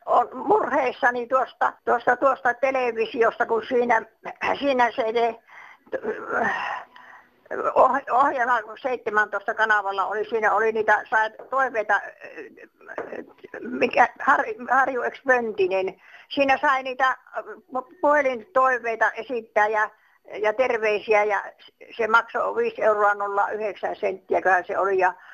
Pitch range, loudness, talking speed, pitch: 210-260 Hz, -23 LUFS, 100 wpm, 230 Hz